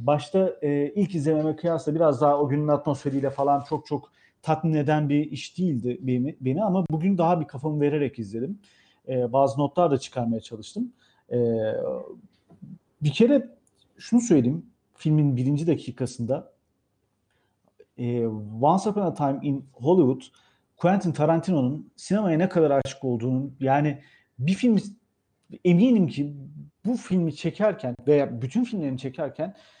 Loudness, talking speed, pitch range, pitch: -25 LUFS, 135 wpm, 135-180 Hz, 150 Hz